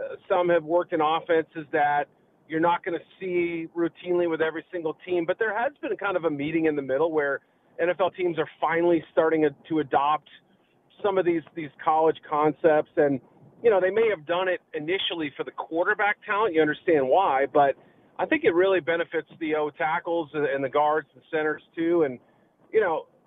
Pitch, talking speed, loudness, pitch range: 165 Hz, 200 wpm, -25 LUFS, 155-180 Hz